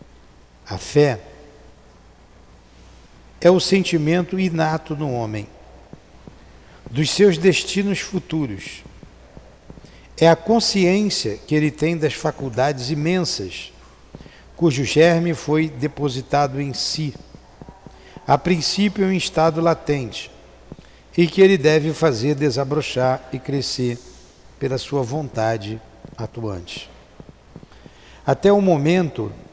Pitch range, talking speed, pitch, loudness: 120-170 Hz, 95 wpm, 150 Hz, -19 LUFS